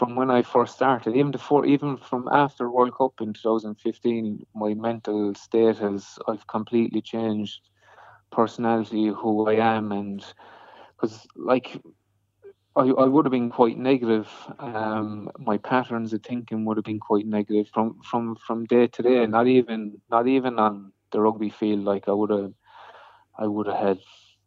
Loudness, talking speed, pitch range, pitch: -24 LUFS, 165 wpm, 105-120 Hz, 110 Hz